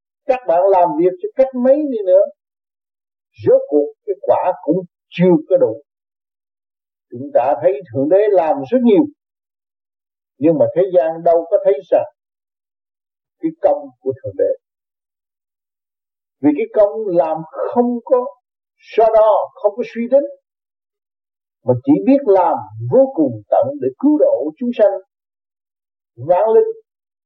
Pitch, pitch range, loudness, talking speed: 255 Hz, 195-295 Hz, -16 LUFS, 140 wpm